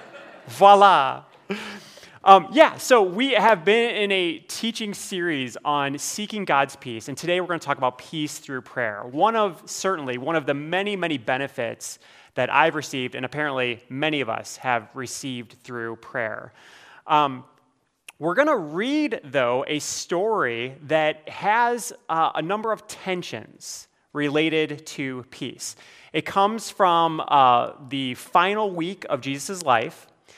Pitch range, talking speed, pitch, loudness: 135-195 Hz, 145 wpm, 155 Hz, -22 LUFS